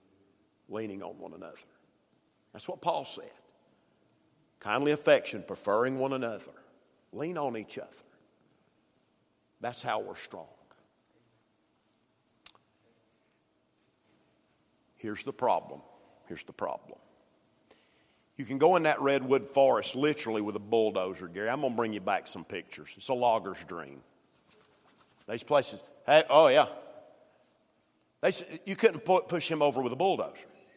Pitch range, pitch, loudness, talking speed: 105-155 Hz, 135 Hz, -29 LUFS, 125 wpm